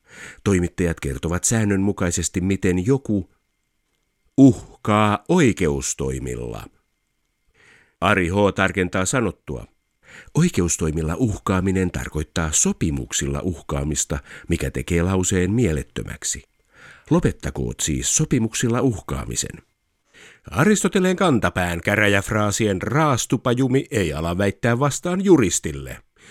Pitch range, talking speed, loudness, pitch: 80-115 Hz, 75 wpm, -21 LUFS, 95 Hz